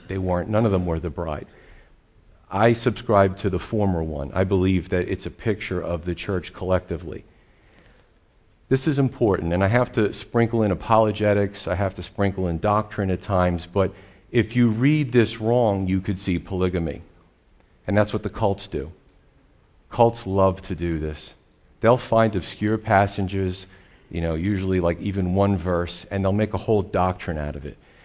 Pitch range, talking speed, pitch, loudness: 90-105 Hz, 180 wpm, 95 Hz, -23 LUFS